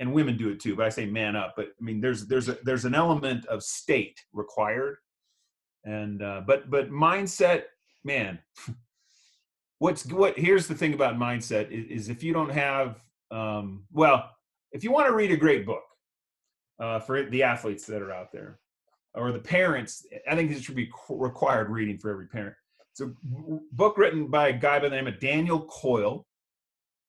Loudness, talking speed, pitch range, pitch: -27 LUFS, 190 wpm, 110-155 Hz, 130 Hz